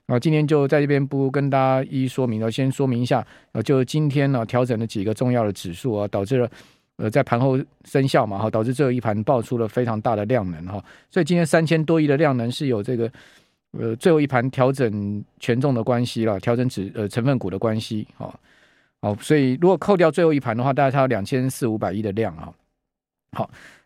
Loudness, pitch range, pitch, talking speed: -21 LUFS, 110-140 Hz, 125 Hz, 325 characters per minute